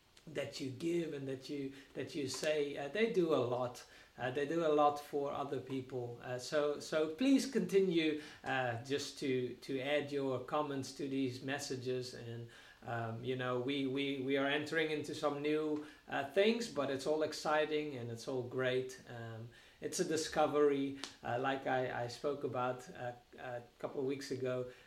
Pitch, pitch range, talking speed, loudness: 140 Hz, 125-150 Hz, 180 wpm, -38 LUFS